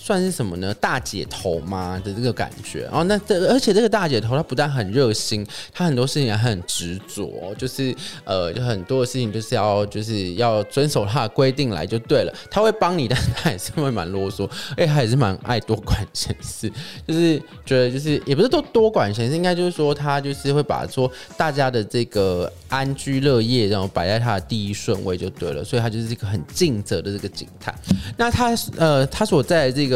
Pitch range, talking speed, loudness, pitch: 105-150 Hz, 315 characters per minute, -21 LUFS, 125 Hz